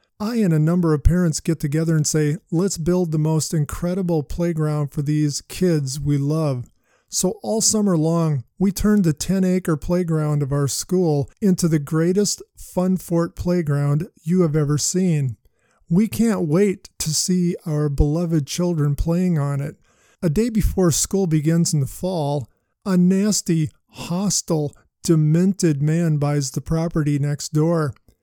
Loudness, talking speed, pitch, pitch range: -20 LUFS, 155 wpm, 165 Hz, 150-180 Hz